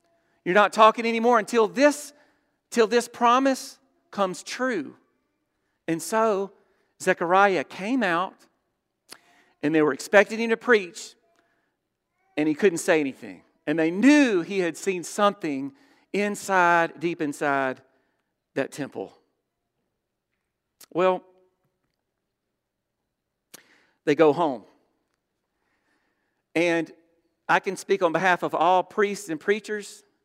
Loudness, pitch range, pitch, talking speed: -23 LUFS, 170-230 Hz, 200 Hz, 110 wpm